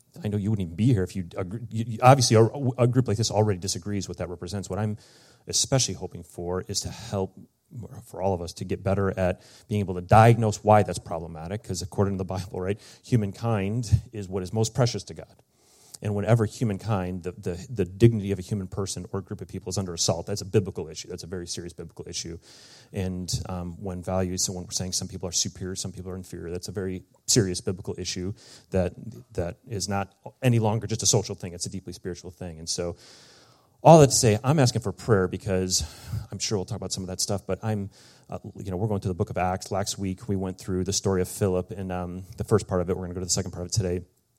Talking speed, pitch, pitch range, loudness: 245 wpm, 100 Hz, 90-110 Hz, -26 LUFS